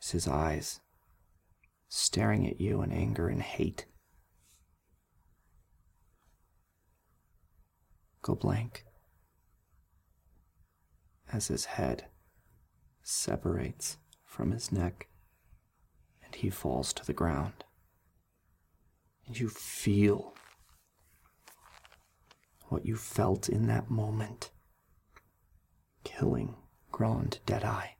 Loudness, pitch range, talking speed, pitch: -33 LUFS, 80-100 Hz, 75 wpm, 90 Hz